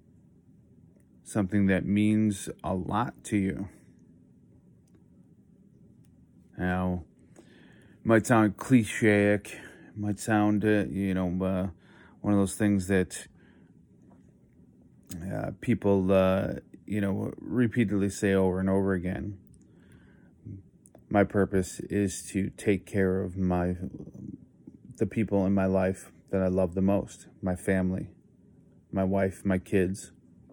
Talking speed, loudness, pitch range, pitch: 115 wpm, -28 LUFS, 95-105 Hz, 95 Hz